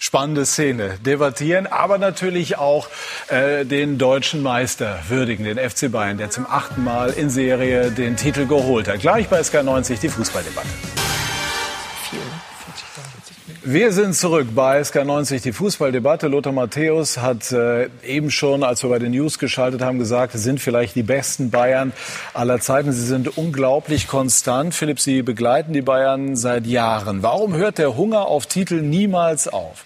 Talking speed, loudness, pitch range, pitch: 155 wpm, -19 LUFS, 125-150 Hz, 135 Hz